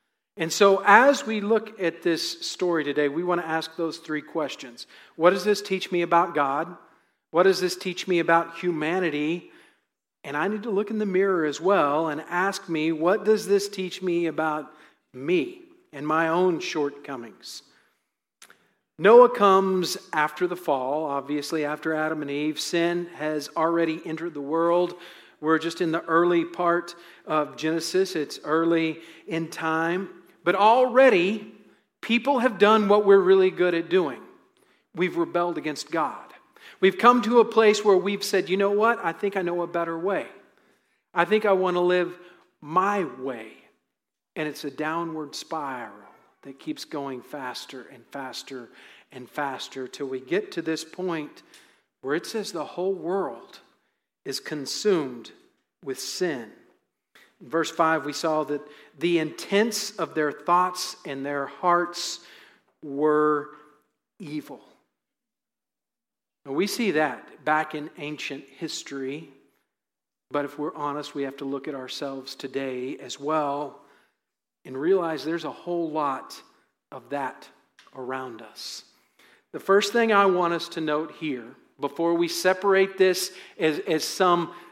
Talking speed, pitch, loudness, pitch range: 150 wpm, 170 Hz, -24 LUFS, 150-185 Hz